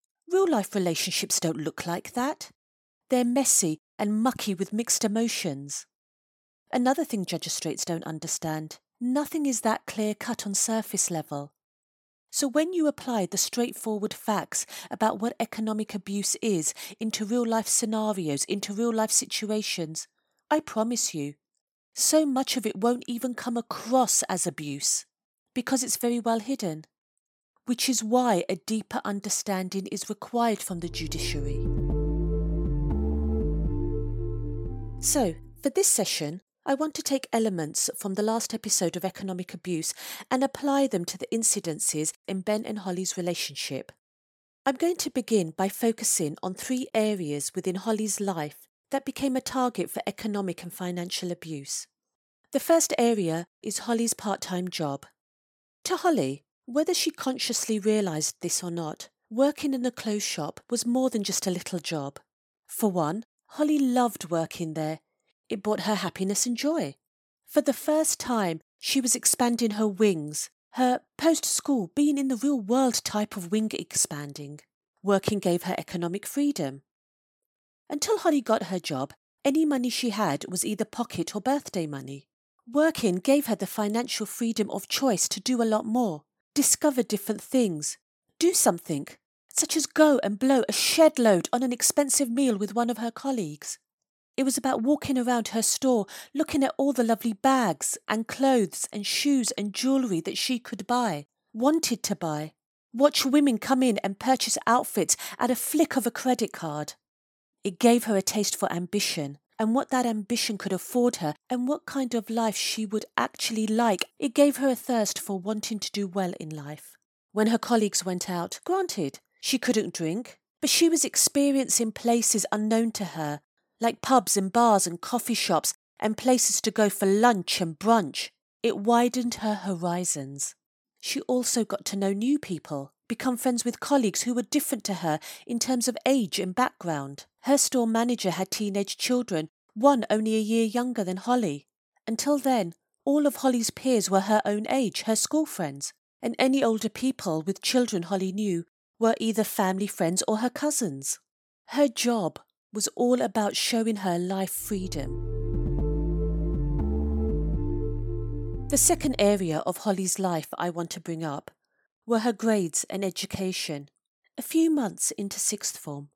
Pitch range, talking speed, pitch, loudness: 180-250 Hz, 160 wpm, 215 Hz, -26 LUFS